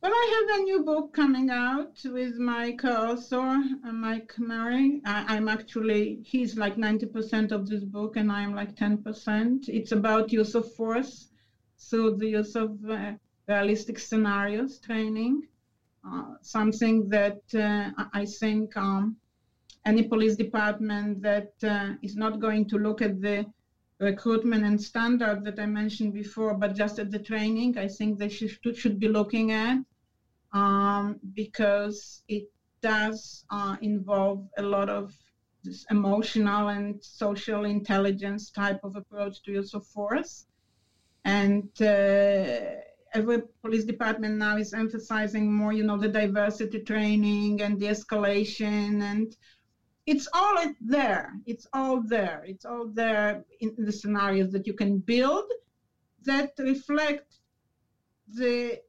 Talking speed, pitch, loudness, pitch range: 140 wpm, 215 Hz, -28 LUFS, 205-230 Hz